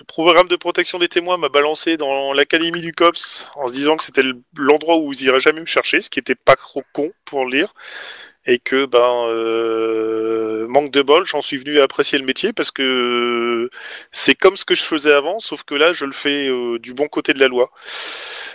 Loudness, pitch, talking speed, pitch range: -17 LUFS, 145 Hz, 220 wpm, 125-165 Hz